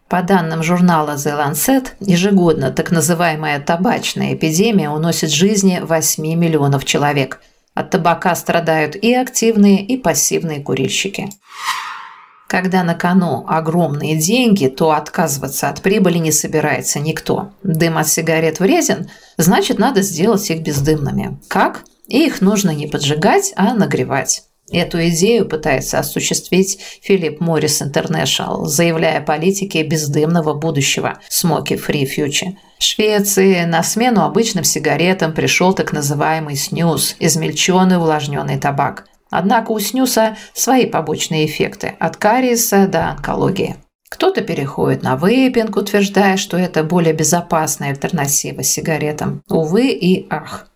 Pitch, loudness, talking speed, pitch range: 170 Hz, -15 LUFS, 125 wpm, 155-195 Hz